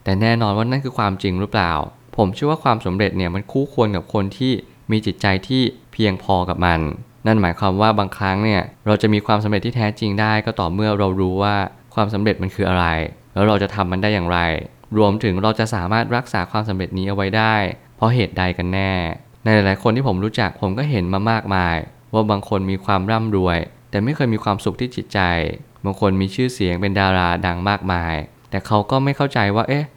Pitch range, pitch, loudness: 95-115 Hz, 105 Hz, -19 LUFS